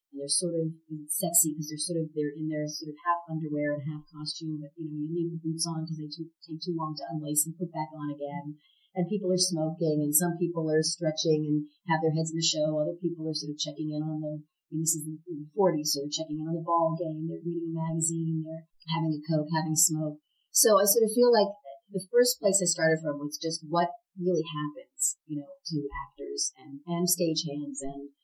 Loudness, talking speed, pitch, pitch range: -29 LUFS, 240 wpm, 160 Hz, 150-170 Hz